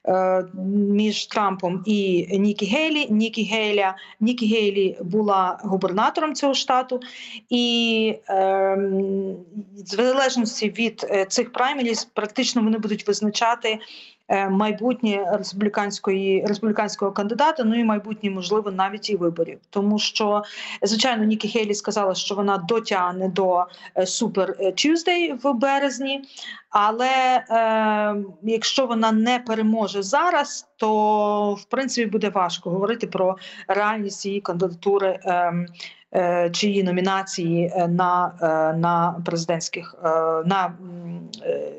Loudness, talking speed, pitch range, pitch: -22 LUFS, 110 wpm, 190-225 Hz, 210 Hz